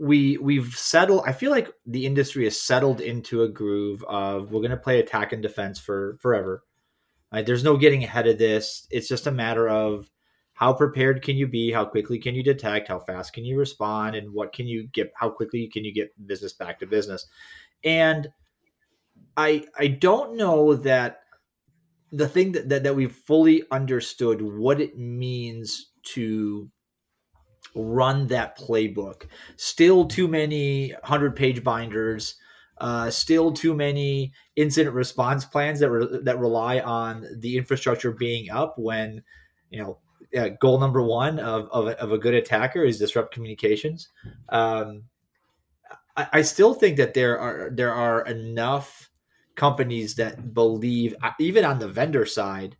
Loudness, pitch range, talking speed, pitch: -23 LUFS, 110-145 Hz, 160 wpm, 125 Hz